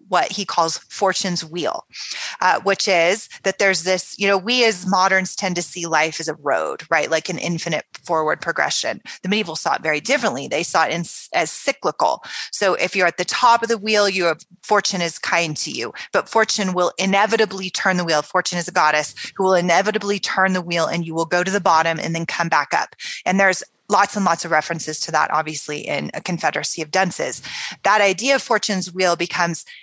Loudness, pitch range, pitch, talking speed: -19 LUFS, 165-200 Hz, 180 Hz, 210 wpm